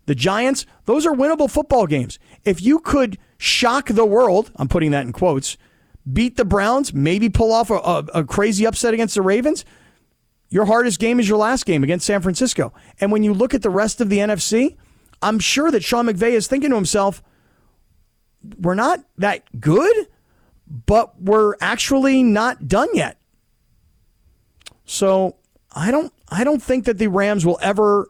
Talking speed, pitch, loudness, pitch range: 175 wpm, 215 Hz, -18 LUFS, 190-245 Hz